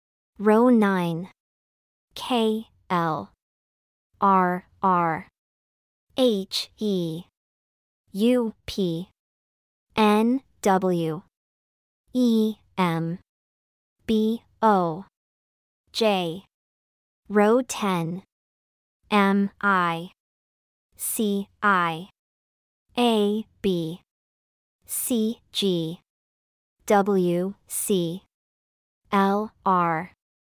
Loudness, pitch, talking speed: -24 LUFS, 180 Hz, 60 wpm